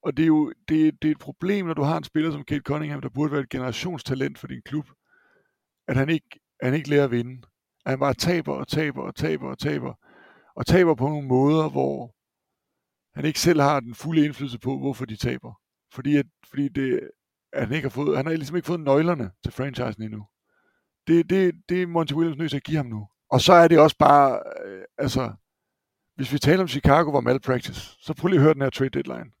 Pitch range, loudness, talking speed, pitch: 135-160 Hz, -23 LUFS, 230 wpm, 145 Hz